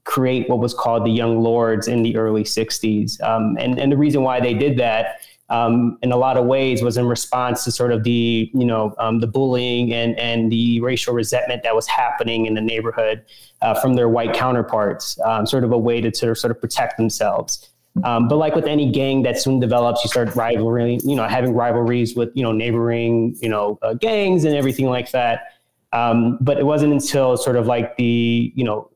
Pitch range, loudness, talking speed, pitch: 115-125 Hz, -19 LUFS, 215 wpm, 120 Hz